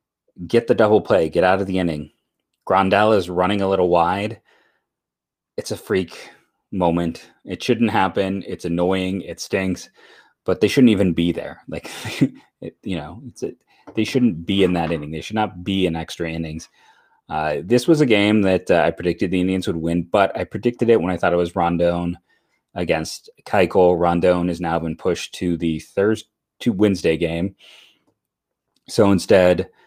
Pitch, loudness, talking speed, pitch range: 90 Hz, -20 LUFS, 180 wpm, 85-100 Hz